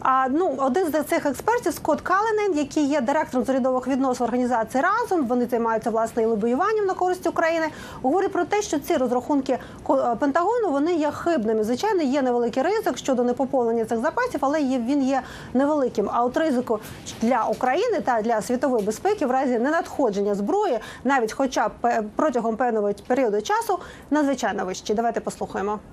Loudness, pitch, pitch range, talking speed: -23 LUFS, 270 Hz, 240-330 Hz, 160 wpm